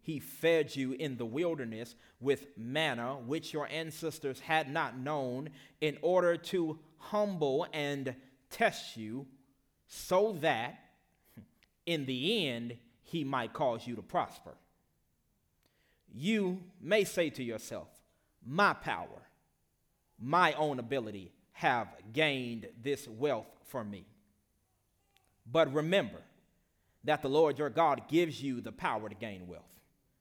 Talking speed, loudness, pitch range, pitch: 125 wpm, -34 LUFS, 115-160 Hz, 135 Hz